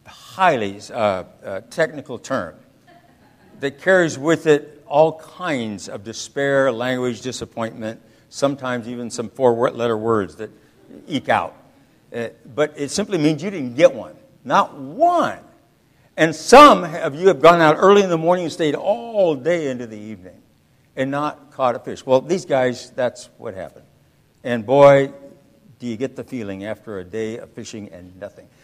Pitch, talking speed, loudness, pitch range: 140 Hz, 165 wpm, -18 LUFS, 115-160 Hz